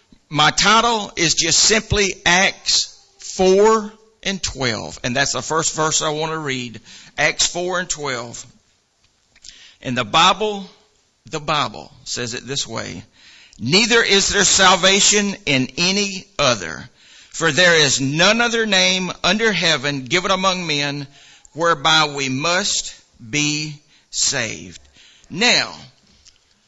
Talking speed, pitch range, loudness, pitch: 125 wpm, 140-195 Hz, -16 LUFS, 165 Hz